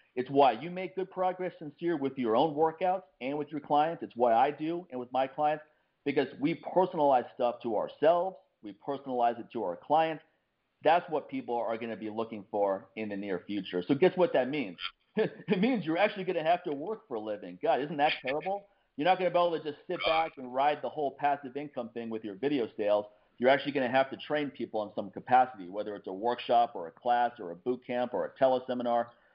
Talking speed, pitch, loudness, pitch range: 235 wpm, 140 Hz, -31 LUFS, 120-170 Hz